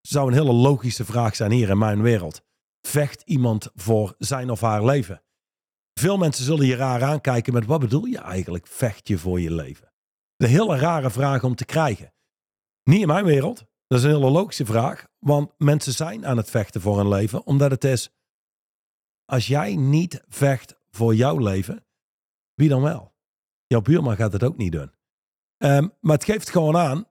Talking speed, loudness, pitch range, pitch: 190 wpm, -21 LUFS, 110-145 Hz, 130 Hz